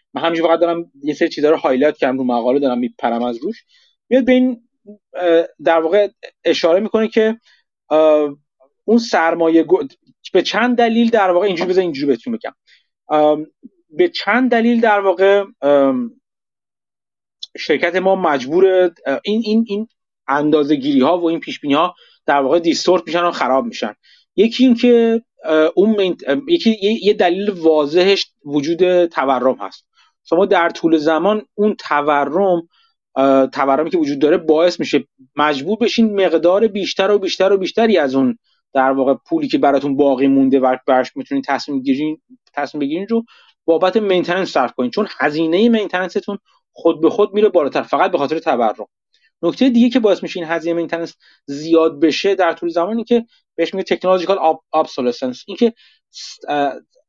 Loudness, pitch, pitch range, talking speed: -16 LUFS, 175 Hz, 150-215 Hz, 150 wpm